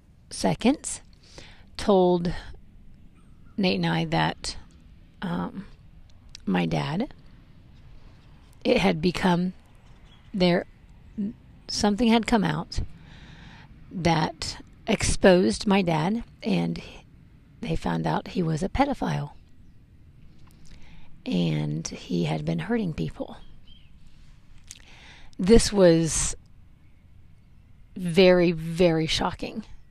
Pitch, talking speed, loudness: 165 Hz, 80 wpm, -25 LUFS